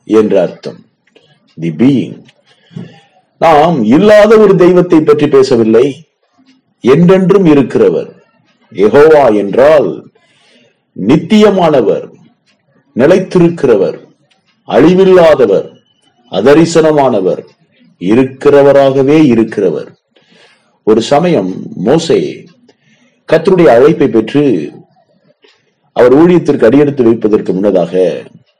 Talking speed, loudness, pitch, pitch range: 65 wpm, -8 LUFS, 160 Hz, 140-200 Hz